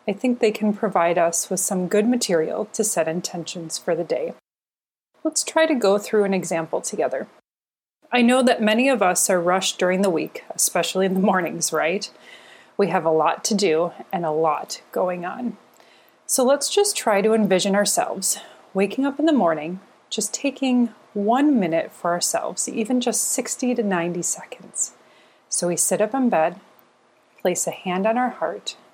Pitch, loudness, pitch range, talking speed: 200 Hz, -21 LUFS, 175-240 Hz, 180 wpm